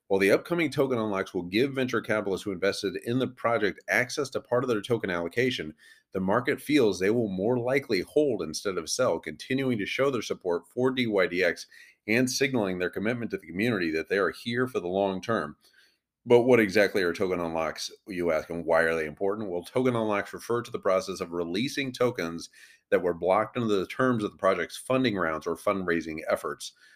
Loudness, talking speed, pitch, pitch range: -27 LUFS, 205 wpm, 105 Hz, 90-125 Hz